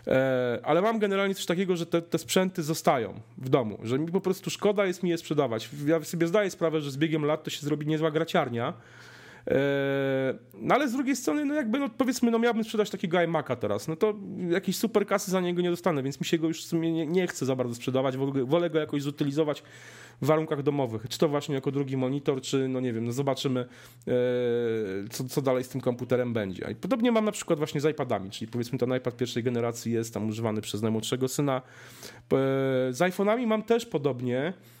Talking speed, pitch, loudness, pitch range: 210 wpm, 150 Hz, -28 LUFS, 130-180 Hz